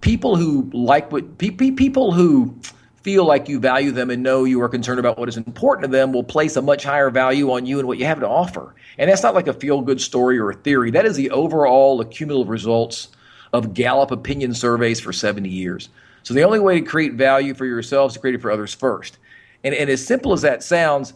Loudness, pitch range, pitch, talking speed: -18 LUFS, 120-145 Hz, 130 Hz, 235 wpm